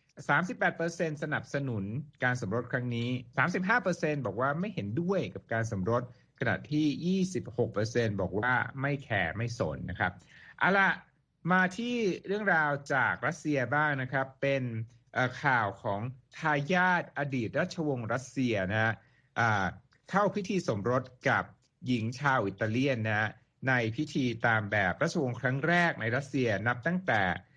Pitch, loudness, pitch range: 130 Hz, -30 LUFS, 115-150 Hz